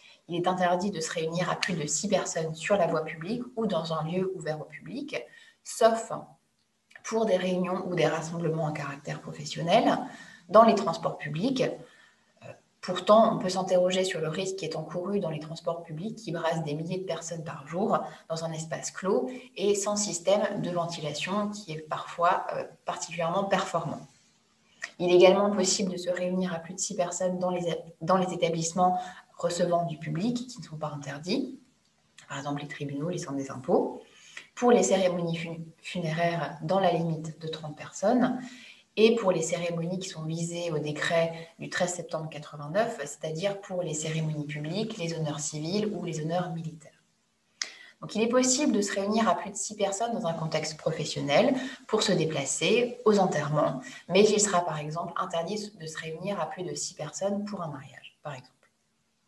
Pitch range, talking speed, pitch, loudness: 160-200 Hz, 180 wpm, 175 Hz, -28 LUFS